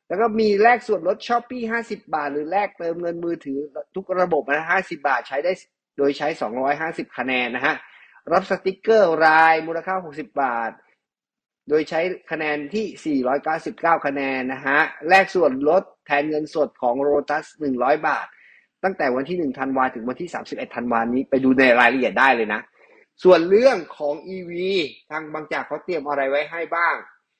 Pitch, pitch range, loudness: 160 Hz, 145-190 Hz, -21 LUFS